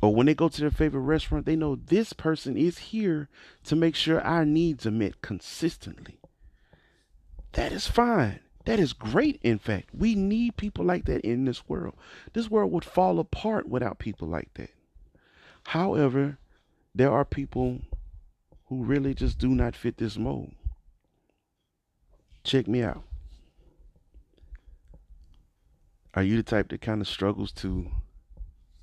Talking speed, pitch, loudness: 150 wpm, 115 Hz, -27 LUFS